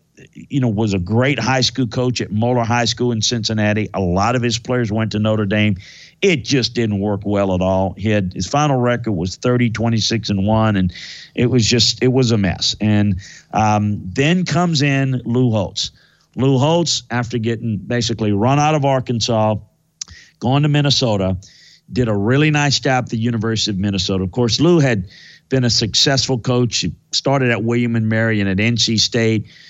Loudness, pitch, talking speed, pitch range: -17 LUFS, 115 Hz, 190 wpm, 105-125 Hz